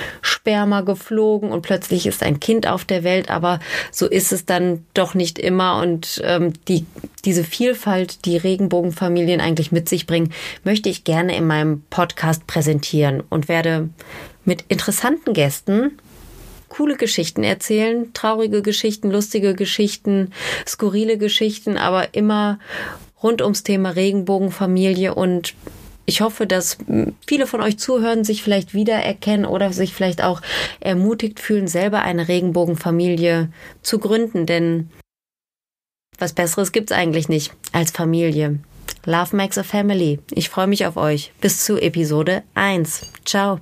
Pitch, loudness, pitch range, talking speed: 185 Hz, -19 LUFS, 170-210 Hz, 140 wpm